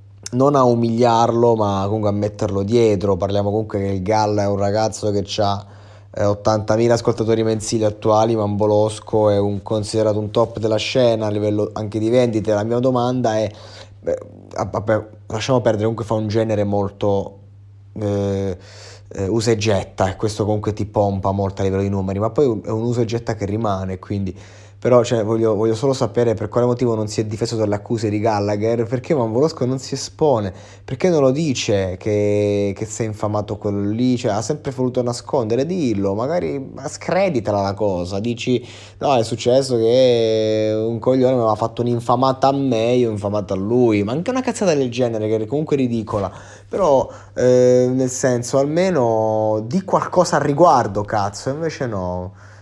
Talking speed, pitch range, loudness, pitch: 175 wpm, 105-120 Hz, -19 LUFS, 110 Hz